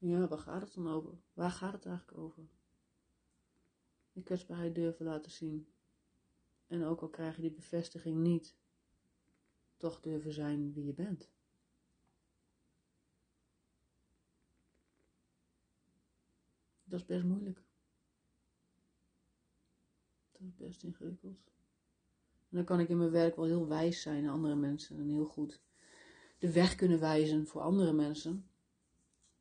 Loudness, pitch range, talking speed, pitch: -37 LUFS, 145-175 Hz, 125 wpm, 160 Hz